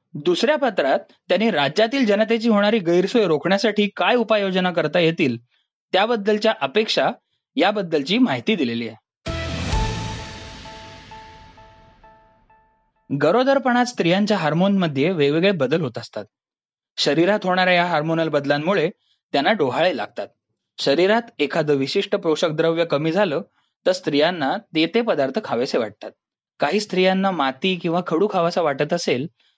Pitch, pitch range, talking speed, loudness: 180 Hz, 145-215 Hz, 115 wpm, -20 LUFS